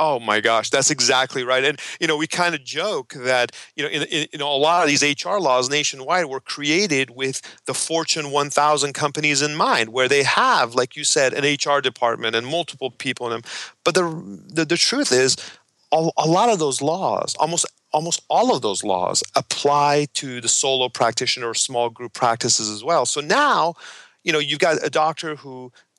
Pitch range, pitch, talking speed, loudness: 130-155 Hz, 145 Hz, 200 wpm, -20 LUFS